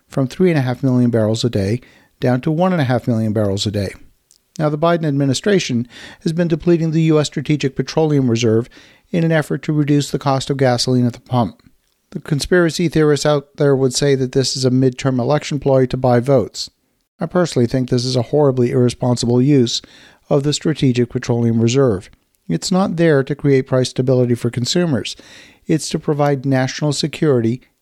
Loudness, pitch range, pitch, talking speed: -17 LUFS, 125-150 Hz, 135 Hz, 175 wpm